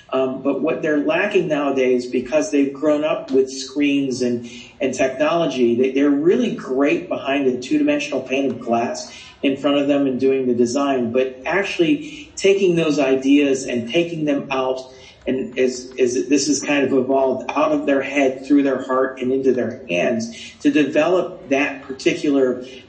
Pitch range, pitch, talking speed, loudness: 130-150 Hz, 135 Hz, 175 wpm, -19 LUFS